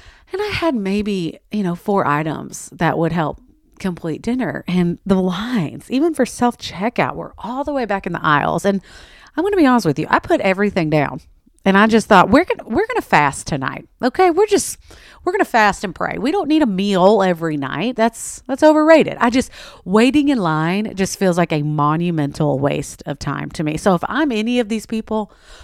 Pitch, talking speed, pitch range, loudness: 210 Hz, 210 wpm, 175-255 Hz, -17 LUFS